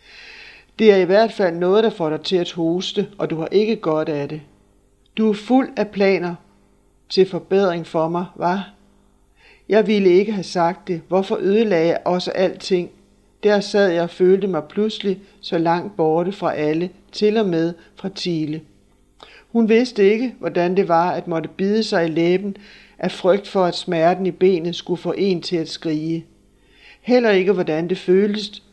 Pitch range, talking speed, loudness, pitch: 170-205 Hz, 180 wpm, -19 LUFS, 180 Hz